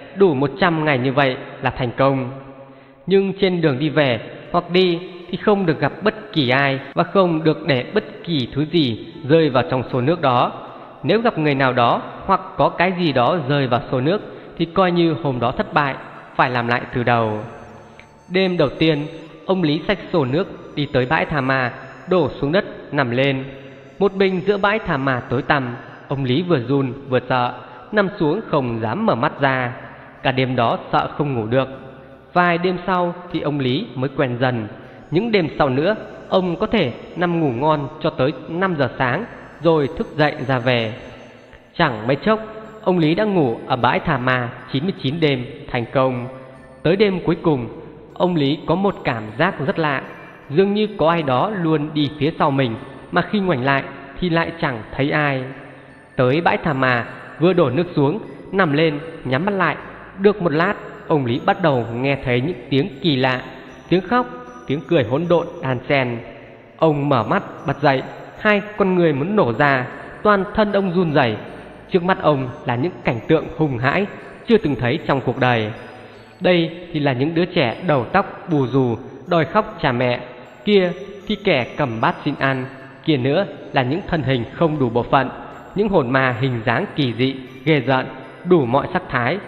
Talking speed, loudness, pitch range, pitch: 195 wpm, -19 LUFS, 130-175 Hz, 145 Hz